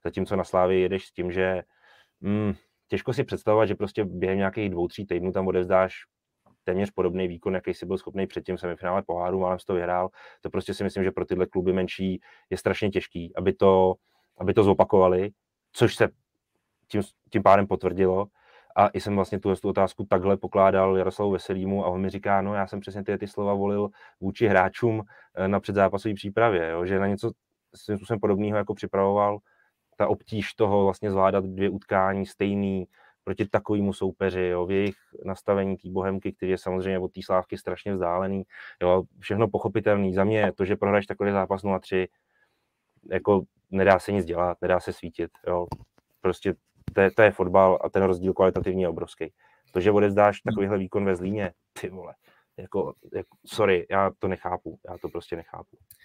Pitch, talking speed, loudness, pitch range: 95 Hz, 185 wpm, -25 LUFS, 95-100 Hz